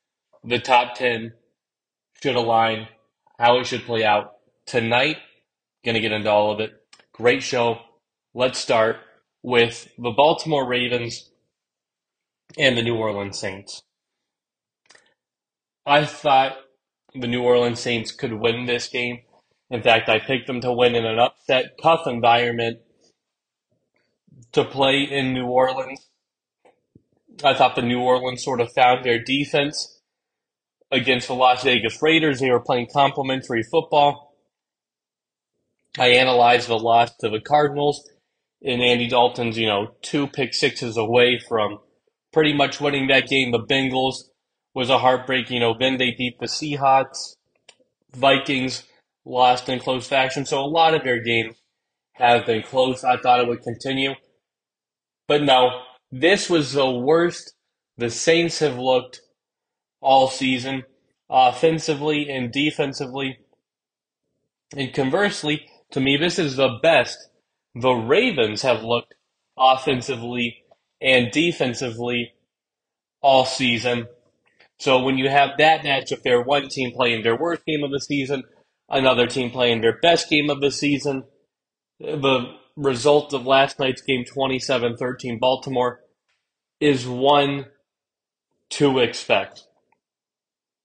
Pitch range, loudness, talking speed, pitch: 120-140 Hz, -20 LUFS, 130 wpm, 130 Hz